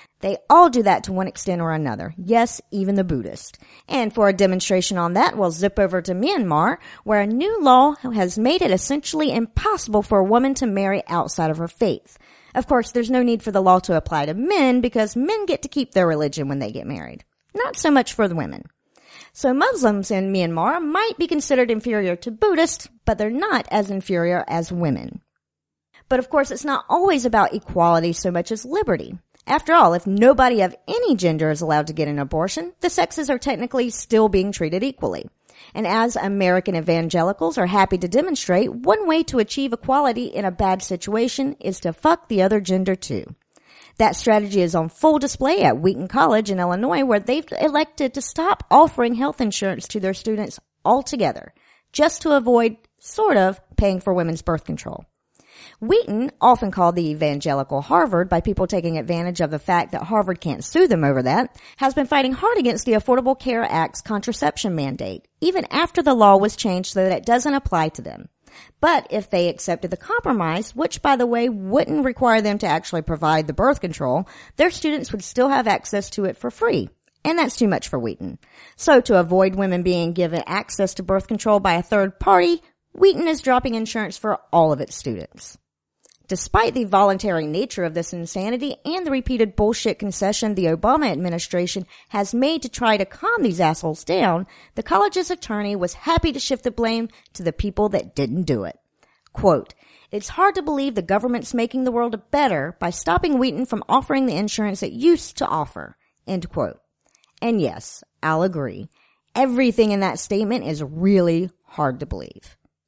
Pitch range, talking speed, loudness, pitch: 180-260 Hz, 190 wpm, -20 LUFS, 210 Hz